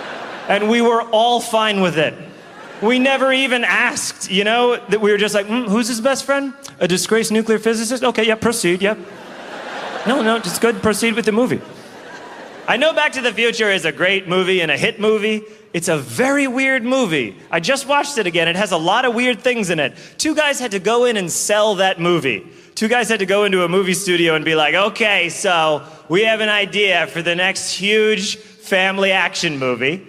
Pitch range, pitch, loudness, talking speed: 185-235 Hz, 215 Hz, -16 LUFS, 215 wpm